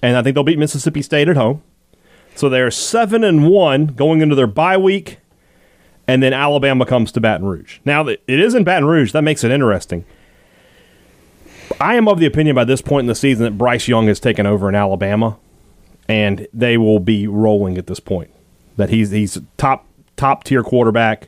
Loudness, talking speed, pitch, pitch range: -15 LUFS, 195 wpm, 125 Hz, 105-150 Hz